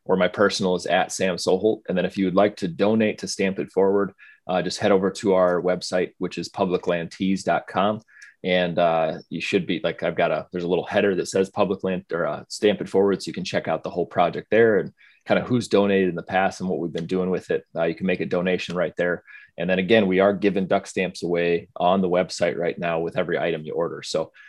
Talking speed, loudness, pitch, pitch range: 250 wpm, -23 LUFS, 95 Hz, 90-100 Hz